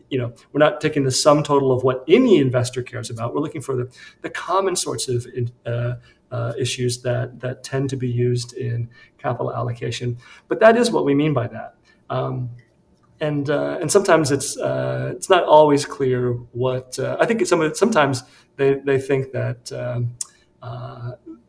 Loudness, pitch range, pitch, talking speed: -20 LUFS, 120-145 Hz, 130 Hz, 185 wpm